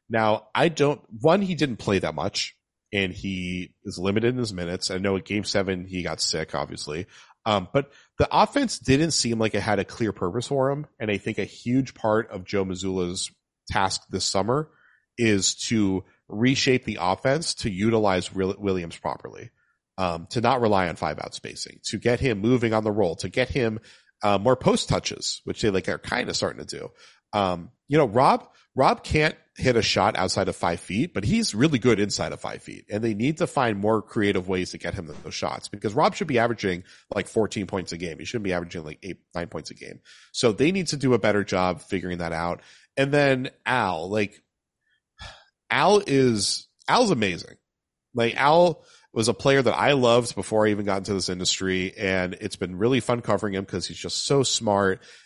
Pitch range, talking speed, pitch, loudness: 95-125 Hz, 205 wpm, 105 Hz, -24 LUFS